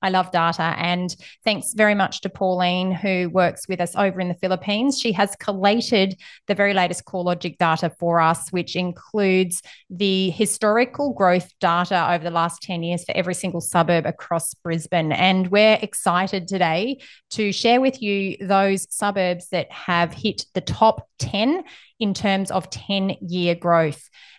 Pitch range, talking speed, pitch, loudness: 175-205 Hz, 160 wpm, 185 Hz, -21 LUFS